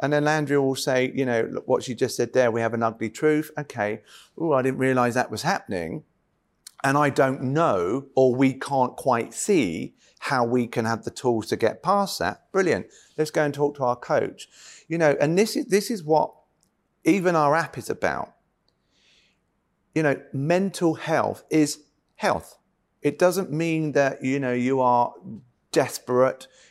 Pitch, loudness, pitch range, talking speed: 140 Hz, -24 LUFS, 125-155 Hz, 180 wpm